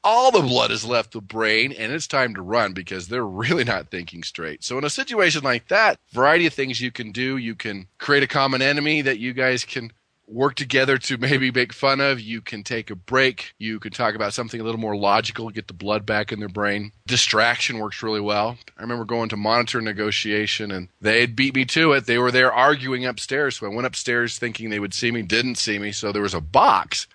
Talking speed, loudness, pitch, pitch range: 235 wpm, -21 LUFS, 115 Hz, 105-130 Hz